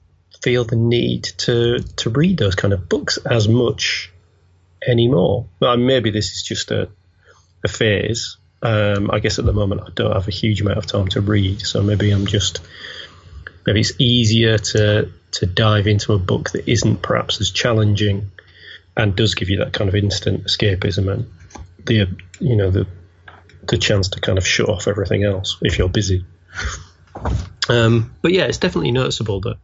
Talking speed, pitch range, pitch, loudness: 180 wpm, 95-115 Hz, 105 Hz, -18 LUFS